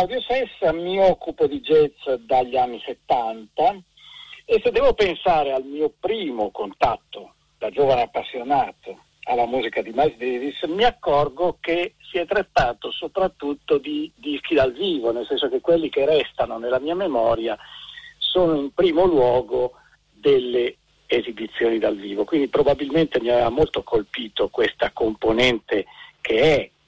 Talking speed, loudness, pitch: 145 wpm, -21 LUFS, 185 Hz